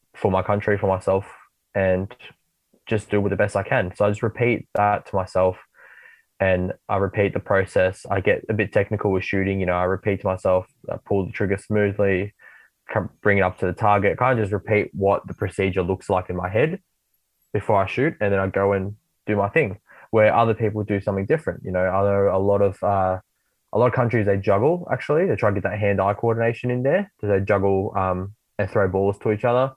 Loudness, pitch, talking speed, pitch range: -22 LUFS, 100 Hz, 230 wpm, 95-105 Hz